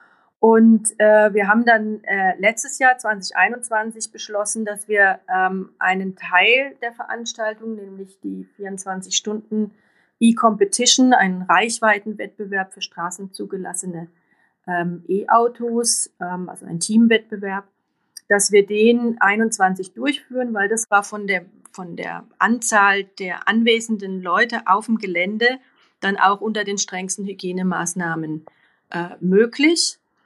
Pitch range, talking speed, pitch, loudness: 190-225 Hz, 115 wpm, 205 Hz, -18 LUFS